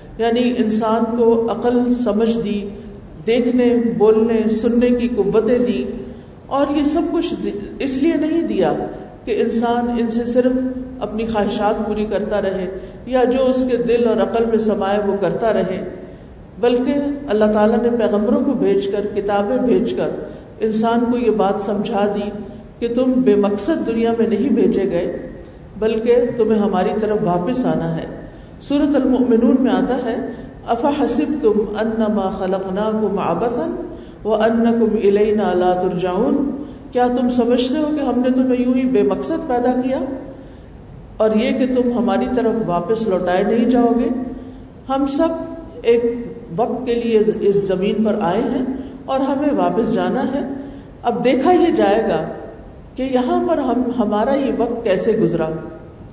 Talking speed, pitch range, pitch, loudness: 155 wpm, 210-255 Hz, 235 Hz, -18 LUFS